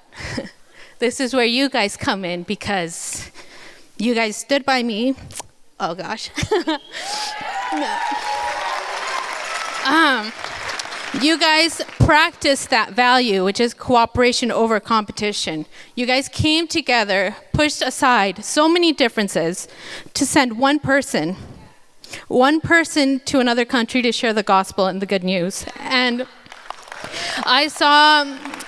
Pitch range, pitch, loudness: 220-300 Hz, 255 Hz, -18 LUFS